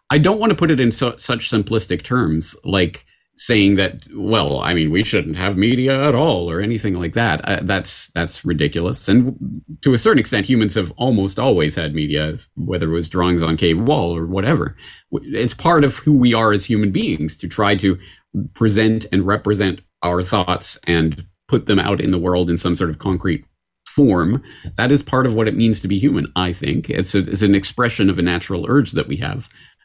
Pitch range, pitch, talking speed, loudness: 90-120 Hz, 100 Hz, 210 wpm, -17 LUFS